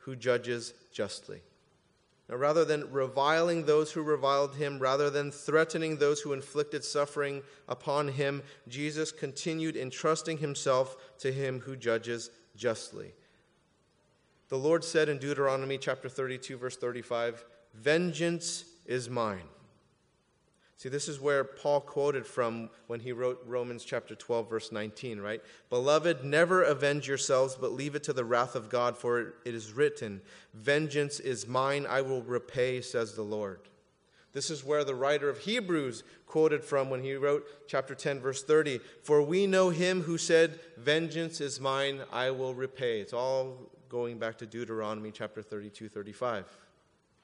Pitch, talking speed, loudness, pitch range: 135 Hz, 150 wpm, -31 LUFS, 120-150 Hz